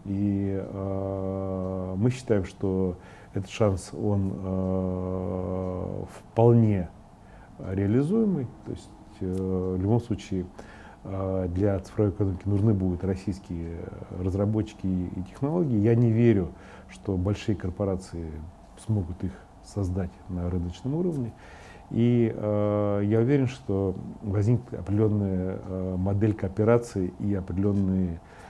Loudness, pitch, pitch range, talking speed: -27 LUFS, 95 Hz, 95-105 Hz, 105 wpm